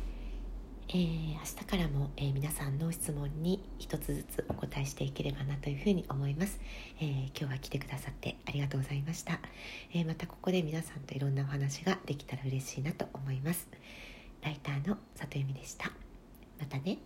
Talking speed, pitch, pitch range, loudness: 380 characters per minute, 145 Hz, 140-165 Hz, -37 LUFS